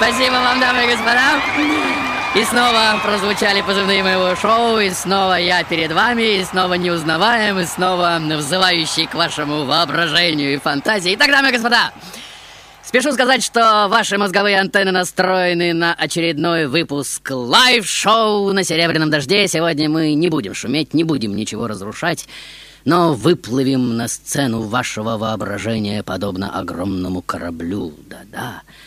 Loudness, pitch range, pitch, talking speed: -16 LUFS, 150-210 Hz, 175 Hz, 135 wpm